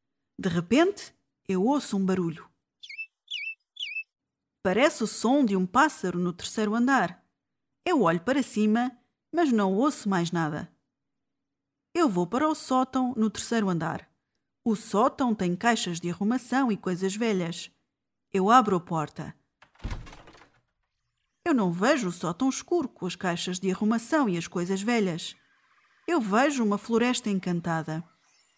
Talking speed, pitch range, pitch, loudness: 135 wpm, 180-255 Hz, 210 Hz, -27 LUFS